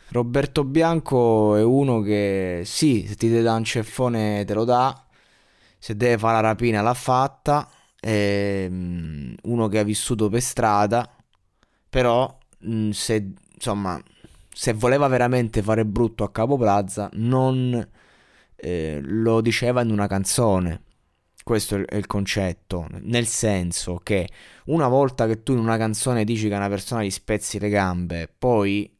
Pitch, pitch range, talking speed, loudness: 110 Hz, 100-120 Hz, 145 wpm, -22 LUFS